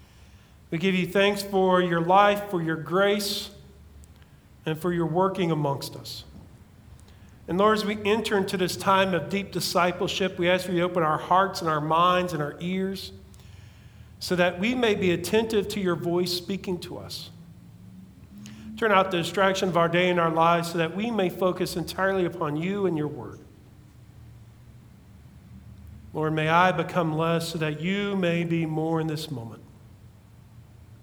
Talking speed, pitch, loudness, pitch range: 170 wpm, 170 Hz, -25 LUFS, 115-185 Hz